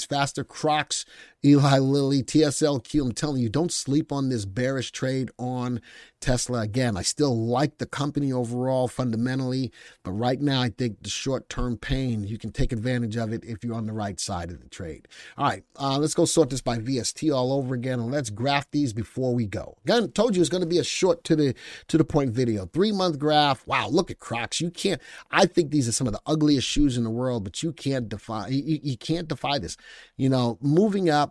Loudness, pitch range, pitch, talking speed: -25 LUFS, 120-150 Hz, 130 Hz, 220 wpm